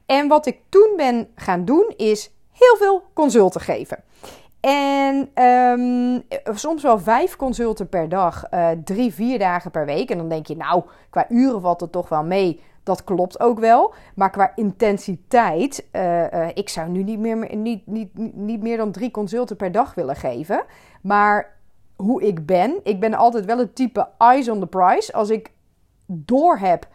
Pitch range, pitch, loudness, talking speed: 190-250 Hz, 220 Hz, -19 LUFS, 180 wpm